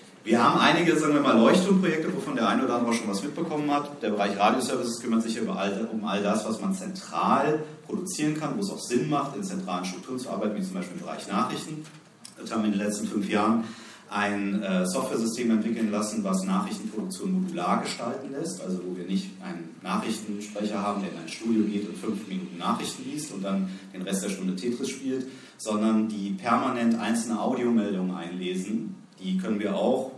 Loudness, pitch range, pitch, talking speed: -27 LUFS, 105-155 Hz, 115 Hz, 200 wpm